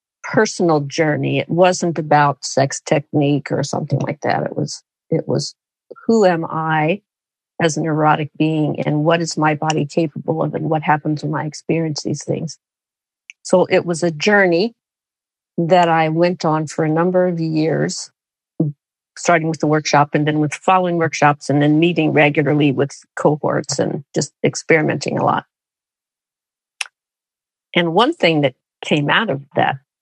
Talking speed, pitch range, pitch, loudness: 160 wpm, 150-170 Hz, 155 Hz, -17 LUFS